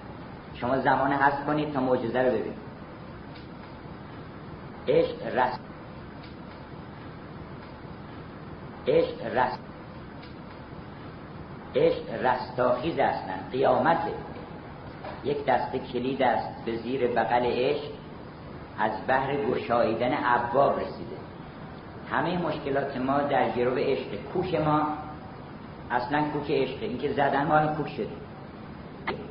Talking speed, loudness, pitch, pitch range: 100 wpm, -27 LUFS, 140 Hz, 125-150 Hz